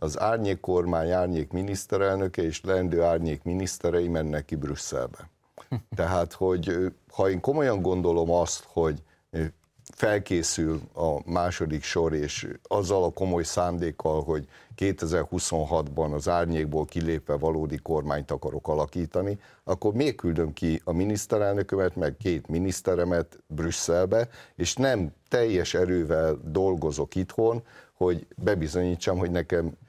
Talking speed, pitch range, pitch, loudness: 115 wpm, 80-95 Hz, 85 Hz, -27 LUFS